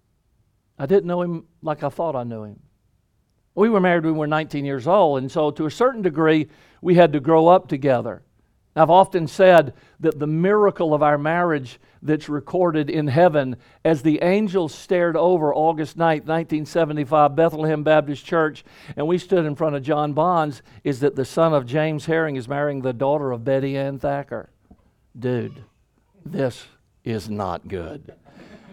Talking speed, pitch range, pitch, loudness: 175 wpm, 140-165 Hz, 155 Hz, -20 LUFS